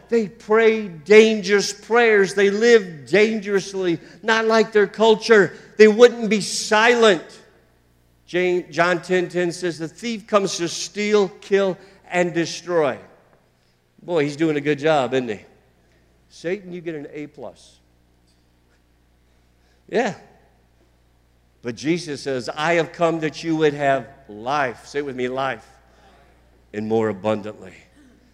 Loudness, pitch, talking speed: -19 LUFS, 165 Hz, 130 wpm